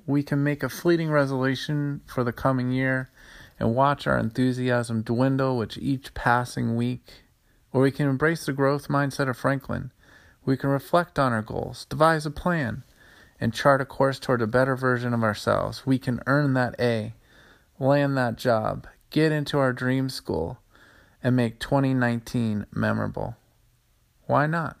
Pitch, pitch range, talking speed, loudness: 130 Hz, 120-140 Hz, 160 wpm, -25 LUFS